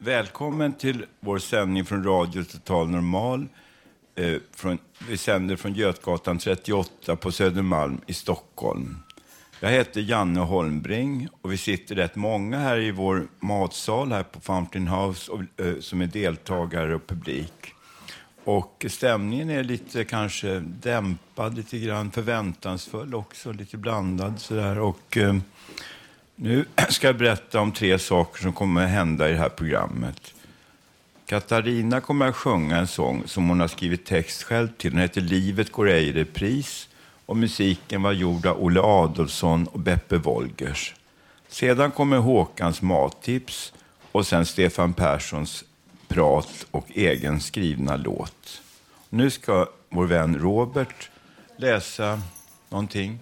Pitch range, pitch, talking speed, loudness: 90-115 Hz, 95 Hz, 140 wpm, -25 LUFS